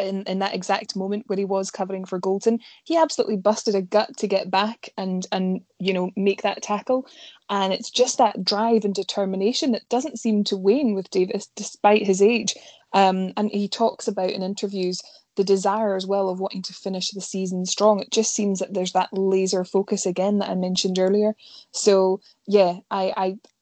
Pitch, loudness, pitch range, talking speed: 200 Hz, -23 LUFS, 190-215 Hz, 200 wpm